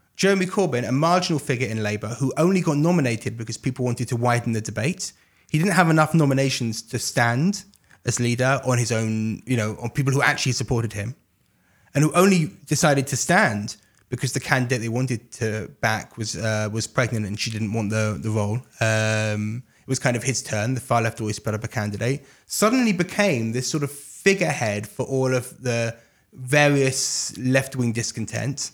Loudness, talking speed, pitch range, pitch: -23 LUFS, 185 wpm, 110-140 Hz, 125 Hz